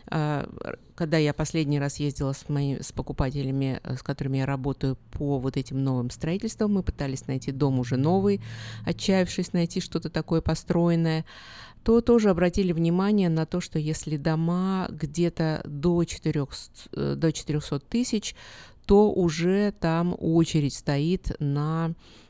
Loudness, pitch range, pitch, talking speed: -26 LUFS, 140-175 Hz, 160 Hz, 130 wpm